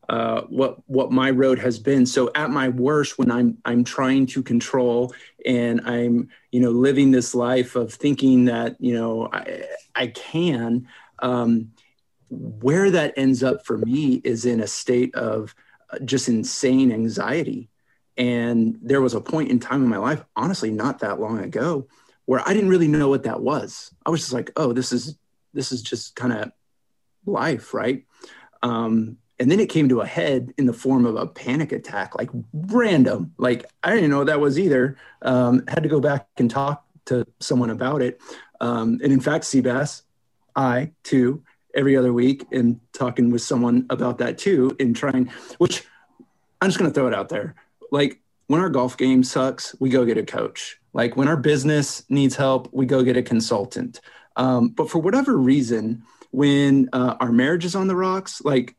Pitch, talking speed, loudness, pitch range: 130 Hz, 190 wpm, -21 LUFS, 120-140 Hz